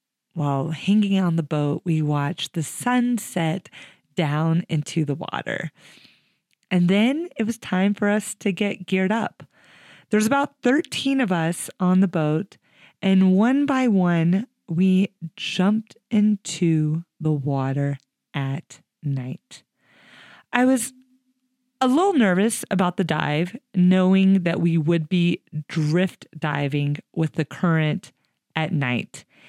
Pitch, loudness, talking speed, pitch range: 180 Hz, -22 LUFS, 130 wpm, 155-210 Hz